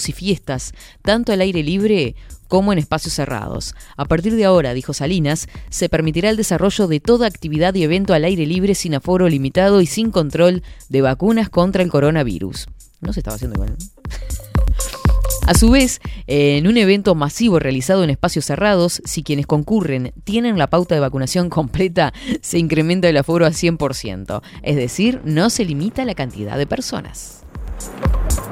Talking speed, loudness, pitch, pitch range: 165 wpm, -17 LUFS, 165 Hz, 140-190 Hz